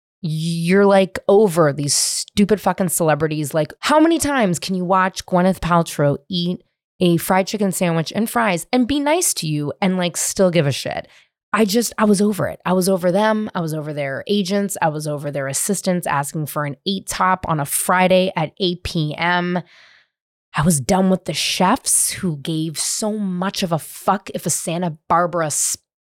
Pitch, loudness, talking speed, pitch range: 180 Hz, -18 LUFS, 190 wpm, 160-195 Hz